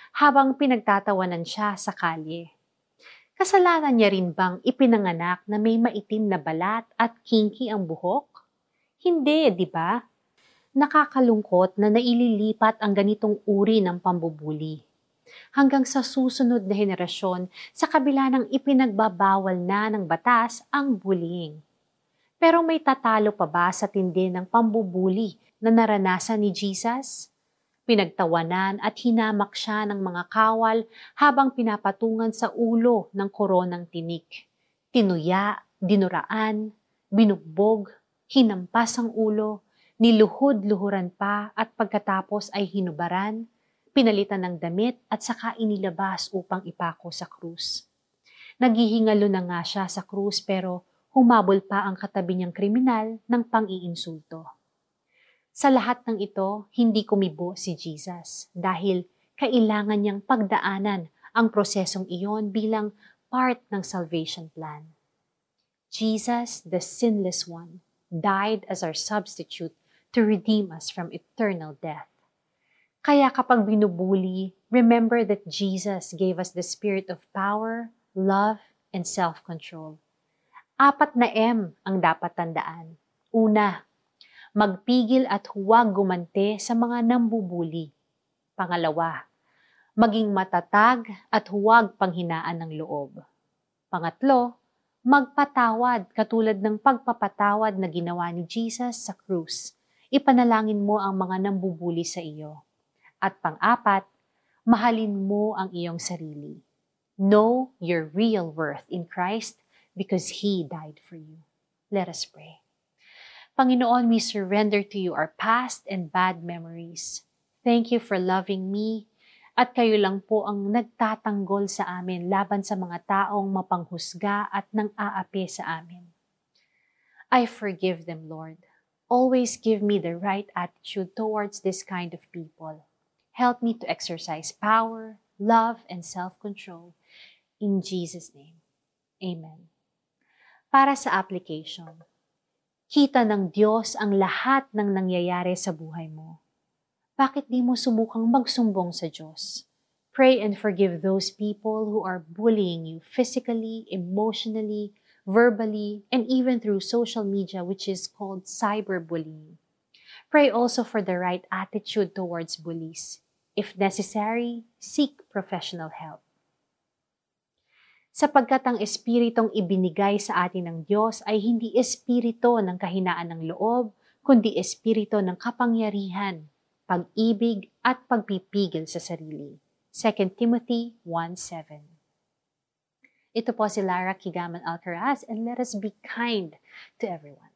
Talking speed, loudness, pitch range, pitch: 120 wpm, -24 LUFS, 180-230 Hz, 205 Hz